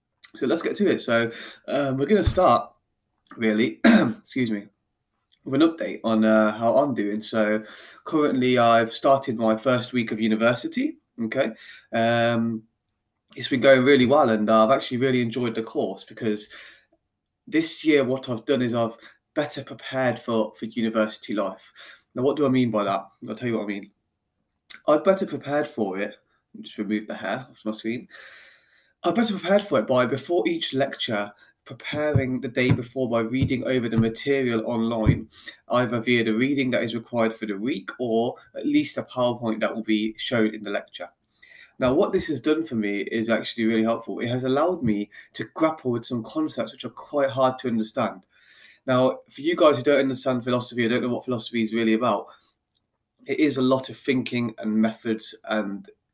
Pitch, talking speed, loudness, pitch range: 120 Hz, 190 wpm, -24 LUFS, 110-135 Hz